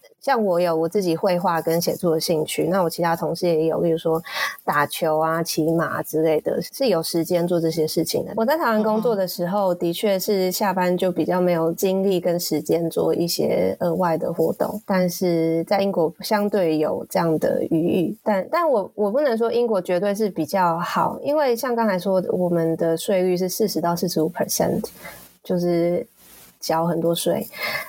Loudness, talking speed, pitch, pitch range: -21 LUFS, 290 characters per minute, 175 Hz, 165-195 Hz